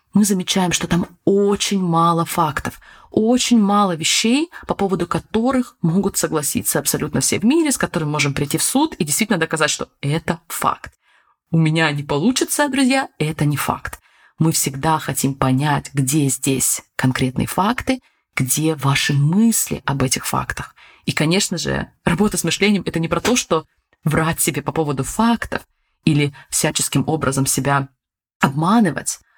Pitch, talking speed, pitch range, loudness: 165 Hz, 155 wpm, 145-200 Hz, -18 LUFS